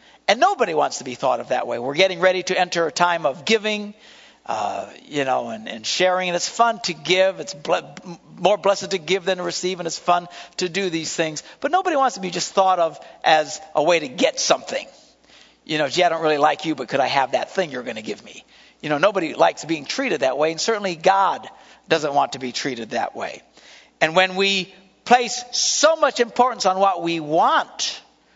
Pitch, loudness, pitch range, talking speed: 185 Hz, -20 LUFS, 165-195 Hz, 225 wpm